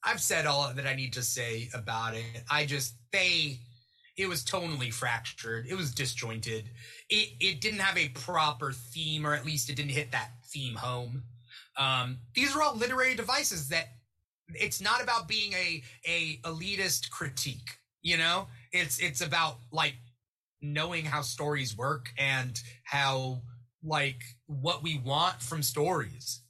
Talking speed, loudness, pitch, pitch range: 155 wpm, -30 LUFS, 140 Hz, 120-165 Hz